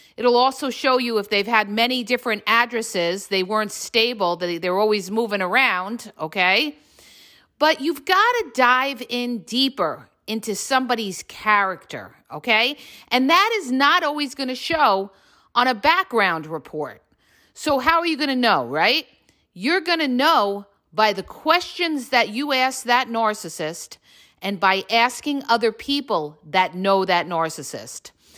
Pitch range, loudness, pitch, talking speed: 195-265 Hz, -20 LUFS, 230 Hz, 150 wpm